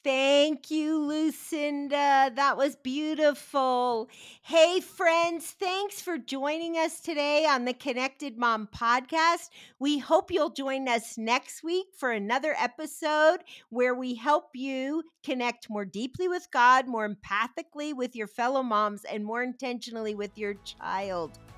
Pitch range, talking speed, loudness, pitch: 240-310 Hz, 135 wpm, -28 LUFS, 275 Hz